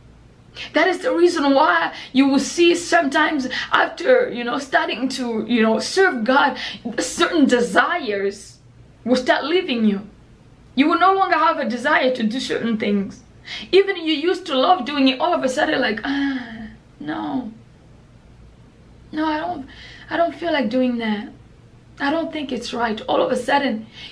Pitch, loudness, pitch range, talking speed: 275 Hz, -19 LUFS, 240-330 Hz, 170 wpm